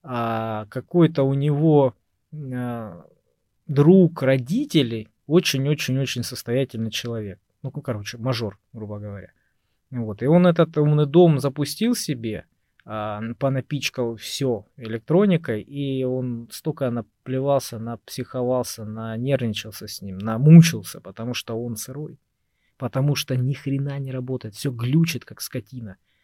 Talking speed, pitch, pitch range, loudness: 115 wpm, 130 Hz, 115-145 Hz, -22 LUFS